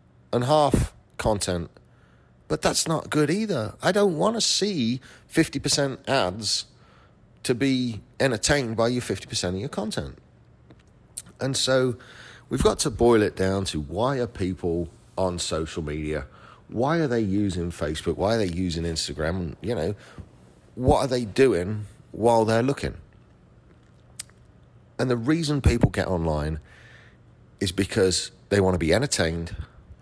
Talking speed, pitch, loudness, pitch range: 145 wpm, 110 Hz, -24 LUFS, 85-130 Hz